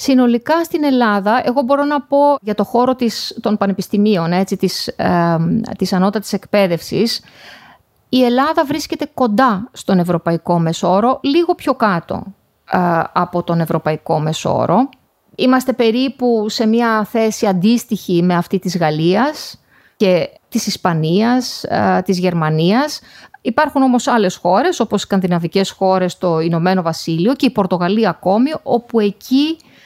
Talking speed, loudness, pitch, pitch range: 135 wpm, -16 LUFS, 210 Hz, 180-250 Hz